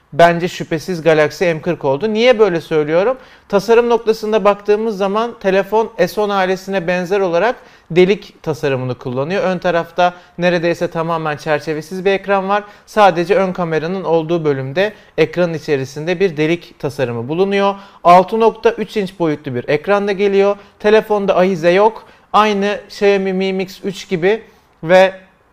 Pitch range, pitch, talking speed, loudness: 170-205 Hz, 190 Hz, 130 wpm, -15 LUFS